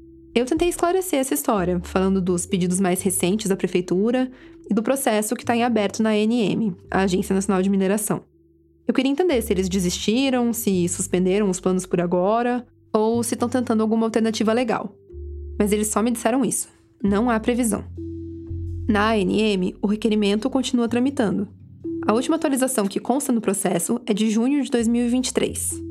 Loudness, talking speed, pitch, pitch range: -21 LUFS, 165 wpm, 215 Hz, 190-245 Hz